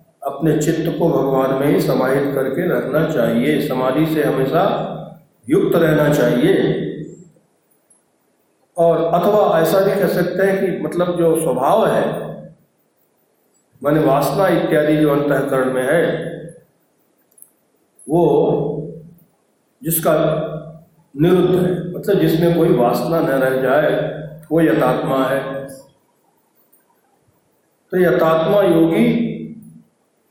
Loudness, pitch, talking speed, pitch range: -16 LUFS, 160 Hz, 105 wpm, 140-175 Hz